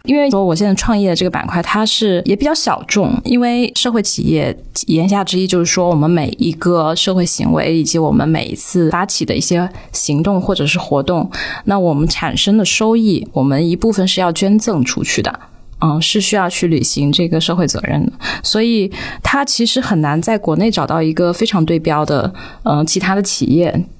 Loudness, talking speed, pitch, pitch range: -14 LUFS, 300 characters per minute, 180 Hz, 165-210 Hz